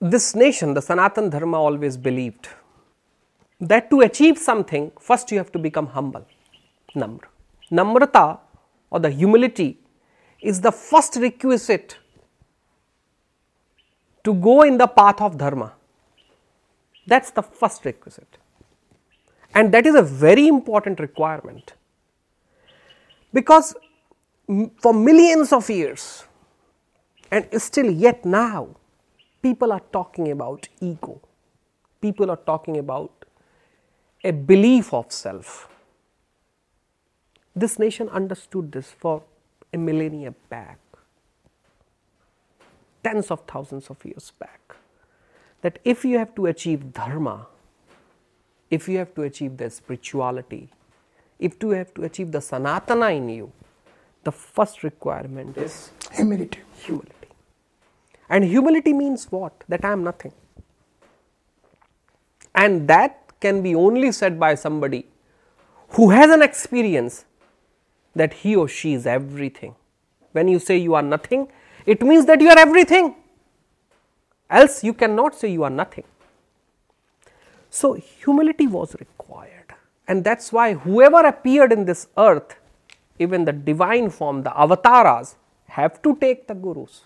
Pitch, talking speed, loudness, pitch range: 195 Hz, 120 wpm, -17 LUFS, 155-240 Hz